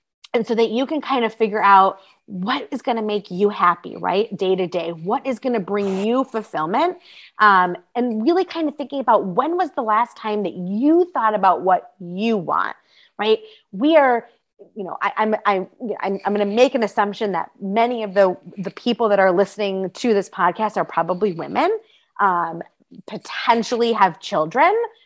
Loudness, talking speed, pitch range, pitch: -20 LUFS, 190 wpm, 195-255 Hz, 215 Hz